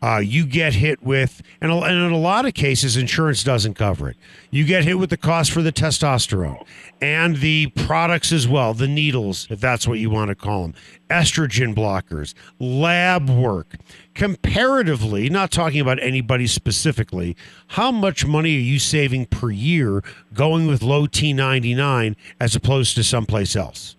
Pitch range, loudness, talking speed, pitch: 110-160 Hz, -19 LUFS, 165 wpm, 135 Hz